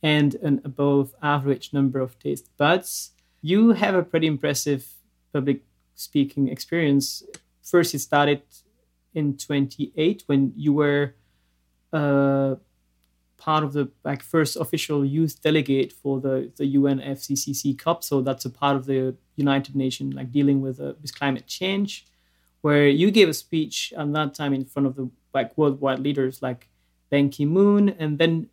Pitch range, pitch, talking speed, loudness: 130-150 Hz, 140 Hz, 155 wpm, -23 LUFS